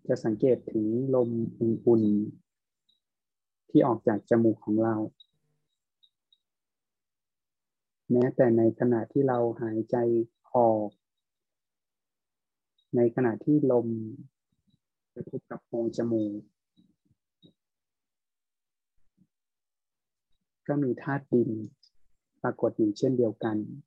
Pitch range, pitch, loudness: 110-125 Hz, 115 Hz, -27 LUFS